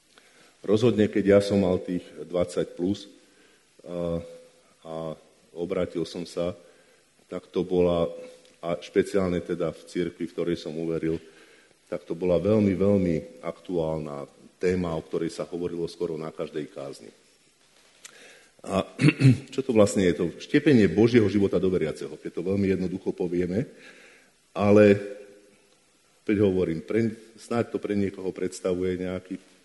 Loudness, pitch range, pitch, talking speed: -26 LUFS, 85-100 Hz, 90 Hz, 130 wpm